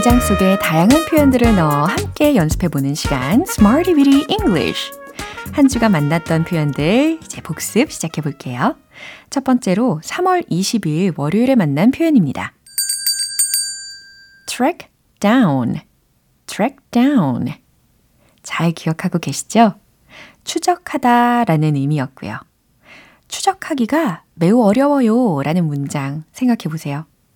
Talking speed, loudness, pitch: 275 characters per minute, -16 LUFS, 235 Hz